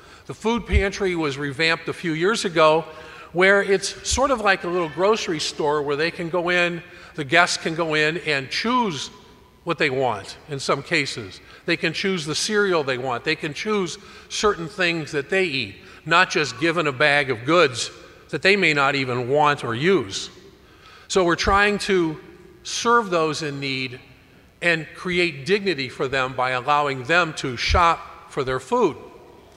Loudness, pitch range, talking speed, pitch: -21 LUFS, 145-190 Hz, 175 wpm, 165 Hz